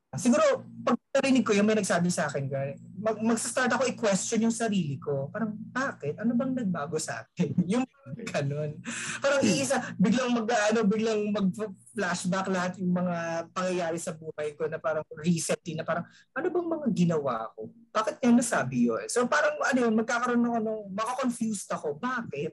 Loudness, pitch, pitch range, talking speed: -28 LUFS, 210 Hz, 165-240 Hz, 170 wpm